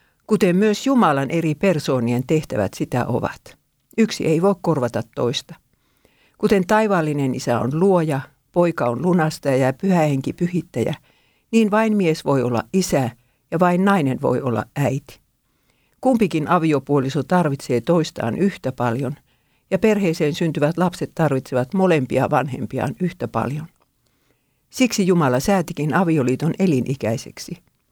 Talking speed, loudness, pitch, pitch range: 125 wpm, -20 LUFS, 155 Hz, 130-185 Hz